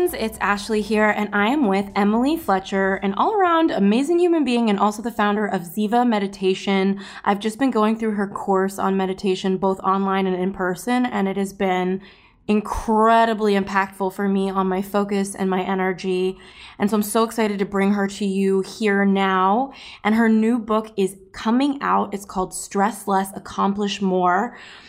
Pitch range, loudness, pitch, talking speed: 195-220 Hz, -21 LUFS, 200 Hz, 180 wpm